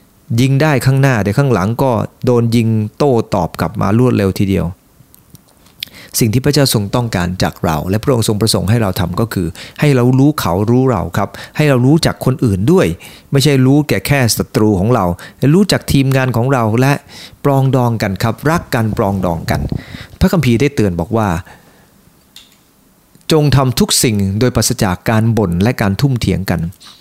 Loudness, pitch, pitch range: -13 LUFS, 115 Hz, 100-135 Hz